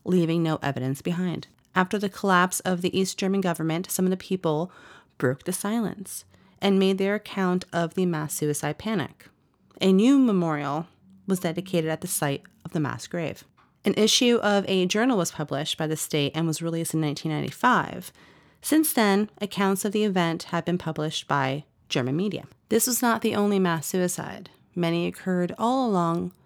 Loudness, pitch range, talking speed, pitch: -25 LUFS, 160-200 Hz, 175 wpm, 180 Hz